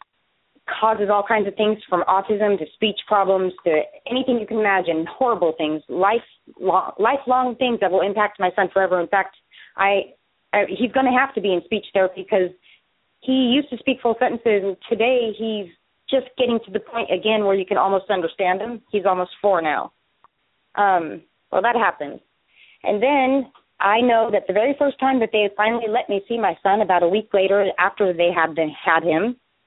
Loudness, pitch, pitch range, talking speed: -20 LUFS, 205 Hz, 190-235 Hz, 190 wpm